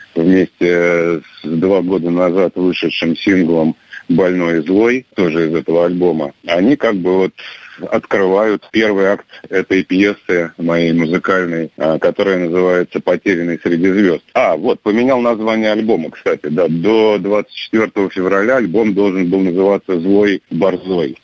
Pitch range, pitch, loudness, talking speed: 85-100 Hz, 95 Hz, -14 LUFS, 130 wpm